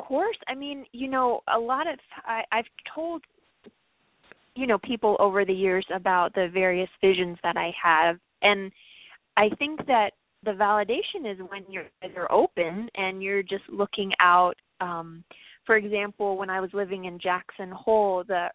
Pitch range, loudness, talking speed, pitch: 185-220 Hz, -25 LUFS, 170 wpm, 200 Hz